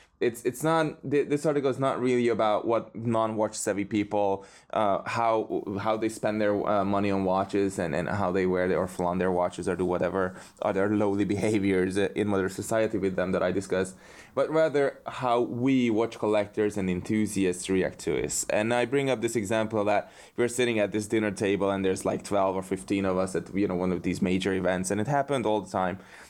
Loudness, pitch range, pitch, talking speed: -27 LUFS, 95-115 Hz, 105 Hz, 210 wpm